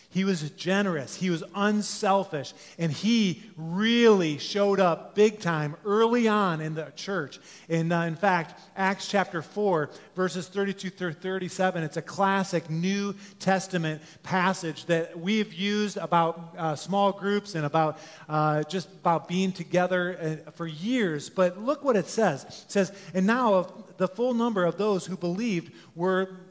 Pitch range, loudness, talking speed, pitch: 165-200 Hz, -27 LUFS, 155 wpm, 185 Hz